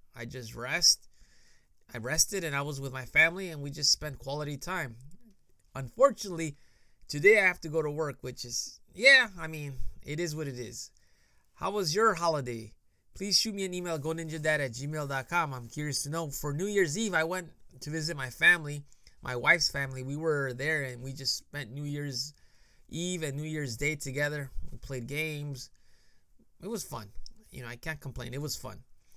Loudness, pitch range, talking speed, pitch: -29 LUFS, 130-160 Hz, 195 wpm, 145 Hz